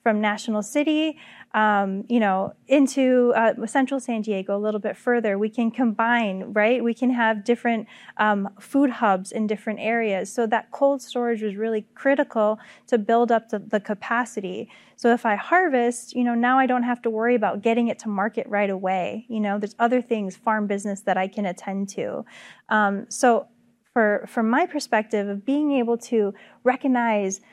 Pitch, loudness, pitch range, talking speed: 225 Hz, -23 LUFS, 210-245 Hz, 185 wpm